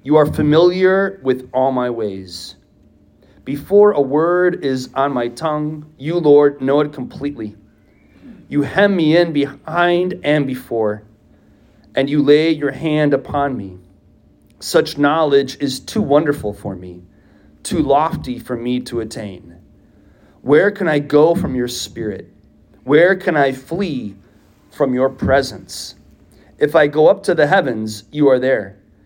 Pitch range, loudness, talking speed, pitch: 105-150 Hz, -16 LUFS, 145 wpm, 135 Hz